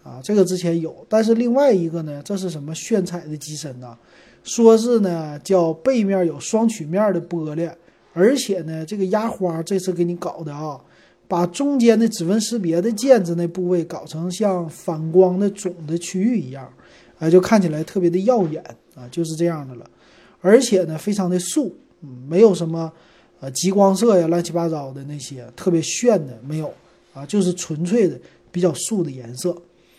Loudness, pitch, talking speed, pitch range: -20 LUFS, 175 Hz, 275 characters per minute, 160-200 Hz